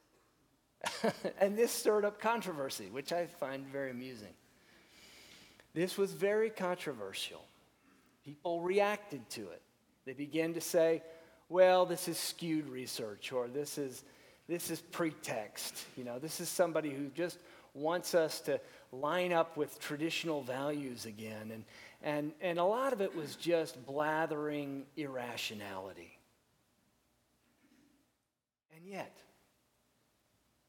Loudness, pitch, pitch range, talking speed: -36 LUFS, 160 Hz, 135-175 Hz, 120 wpm